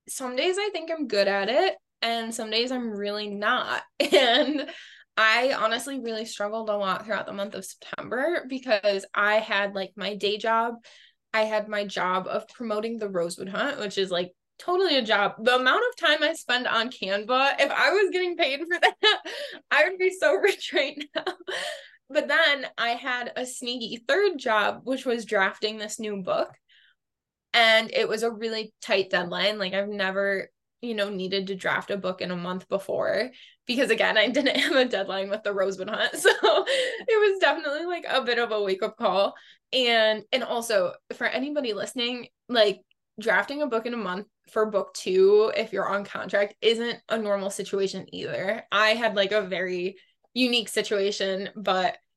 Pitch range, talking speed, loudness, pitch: 200-275 Hz, 185 wpm, -25 LUFS, 225 Hz